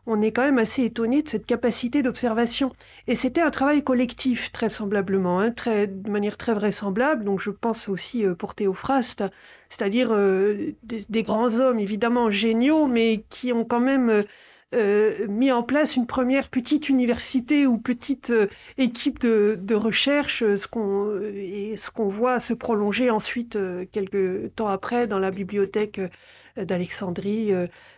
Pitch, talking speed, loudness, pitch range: 225 Hz, 155 wpm, -23 LUFS, 205-250 Hz